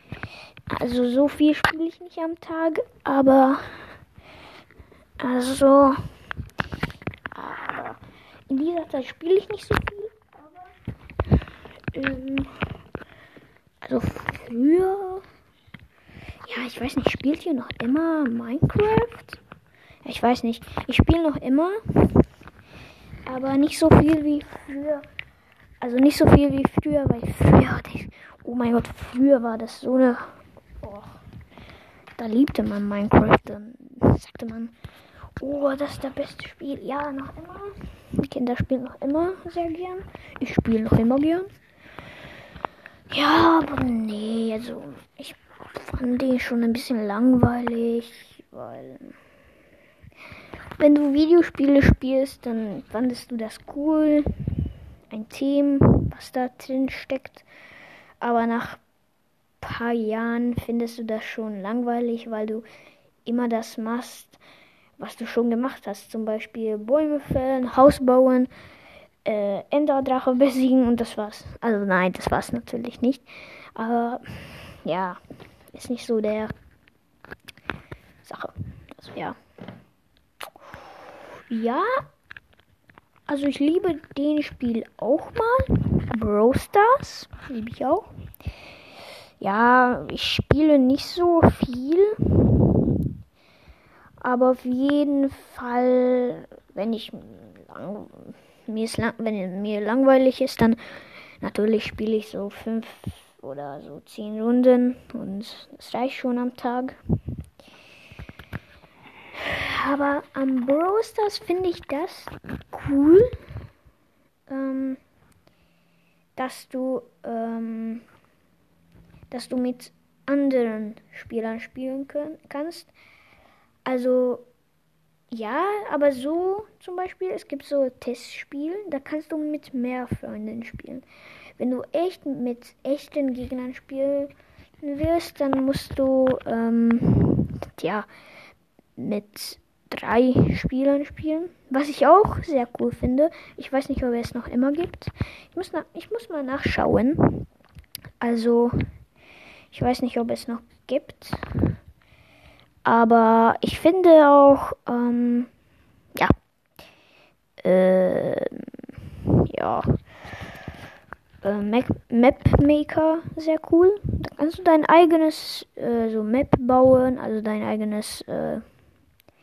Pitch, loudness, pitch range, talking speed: 260 Hz, -22 LUFS, 235-295 Hz, 115 wpm